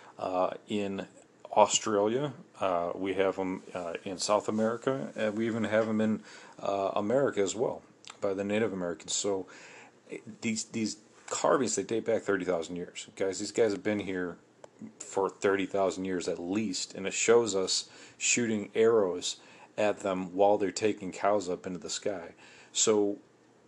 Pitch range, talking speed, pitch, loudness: 95-110 Hz, 160 wpm, 100 Hz, -30 LUFS